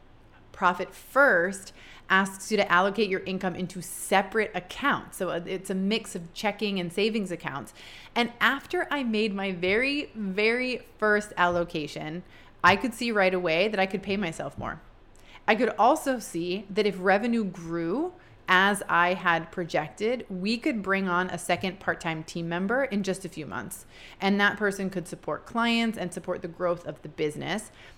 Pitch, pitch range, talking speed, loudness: 190 Hz, 175-215 Hz, 170 wpm, -27 LUFS